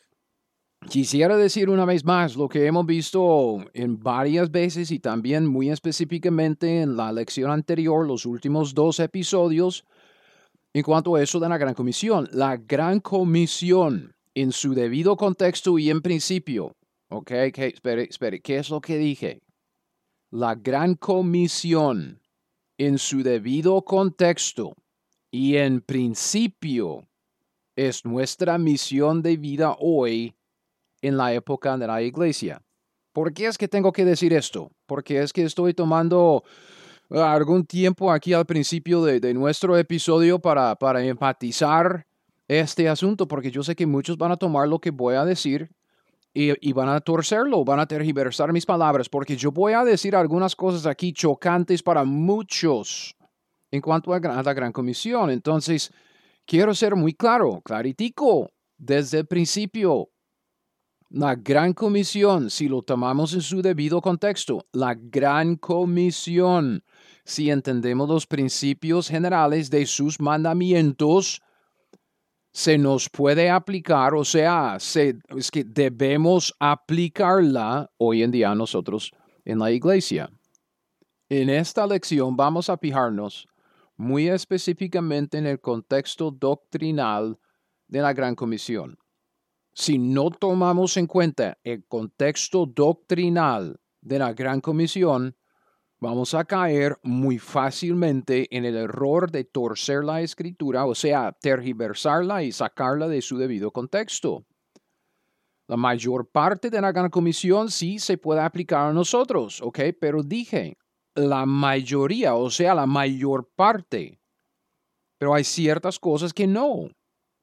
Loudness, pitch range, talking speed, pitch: -22 LUFS, 135-175 Hz, 135 wpm, 155 Hz